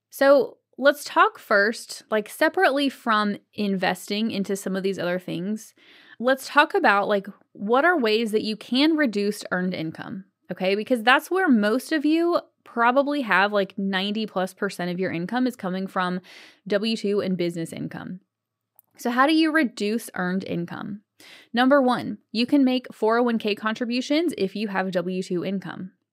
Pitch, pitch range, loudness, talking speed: 220 Hz, 195-270 Hz, -23 LUFS, 165 wpm